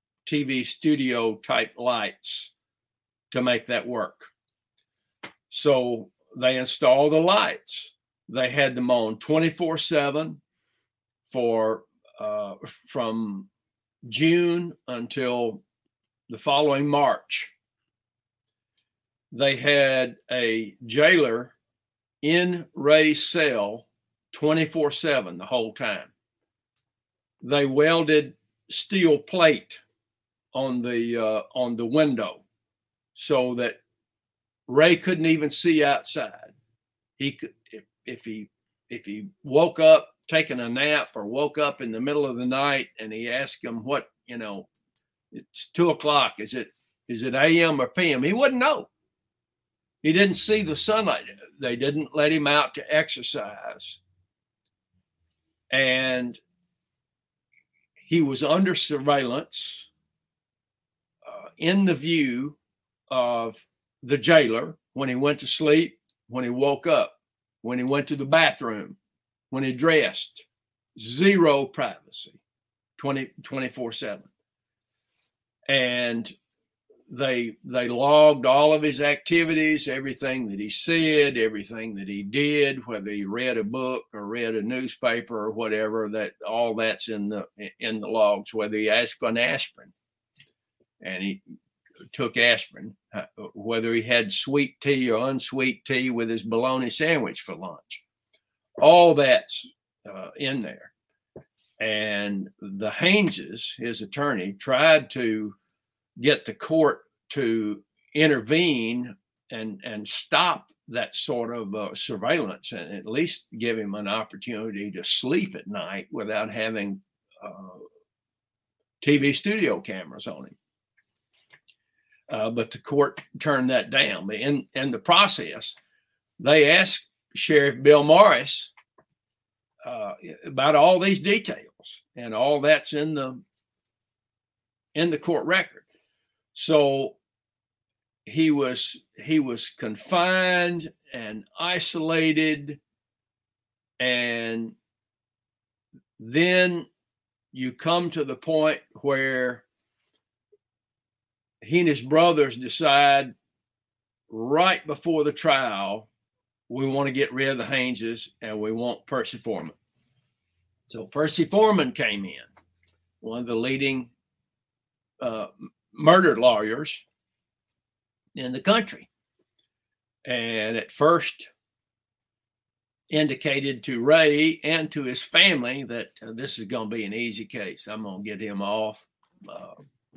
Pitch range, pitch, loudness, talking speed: 115-150 Hz, 125 Hz, -23 LUFS, 120 wpm